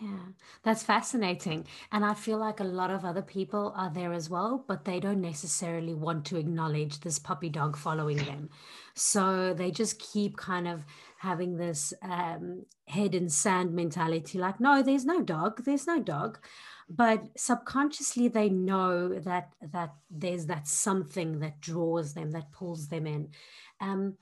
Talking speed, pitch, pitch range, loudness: 165 wpm, 180 Hz, 165-205 Hz, -31 LUFS